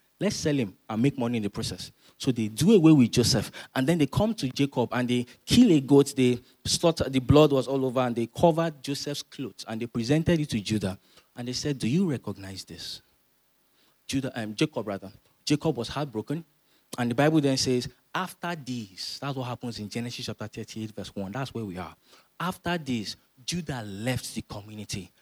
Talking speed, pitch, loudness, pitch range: 200 wpm, 125 Hz, -27 LUFS, 110-145 Hz